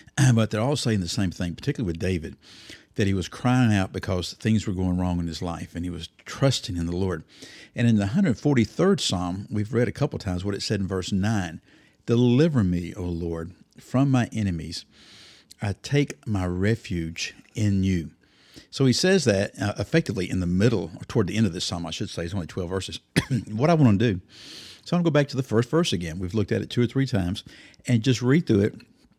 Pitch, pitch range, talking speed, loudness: 105 Hz, 90-120 Hz, 225 wpm, -25 LUFS